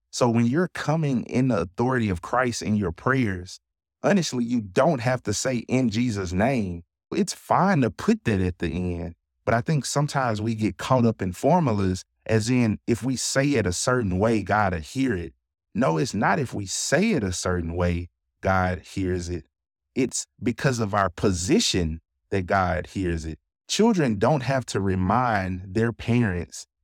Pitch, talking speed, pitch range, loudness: 105 Hz, 180 wpm, 90-125 Hz, -24 LUFS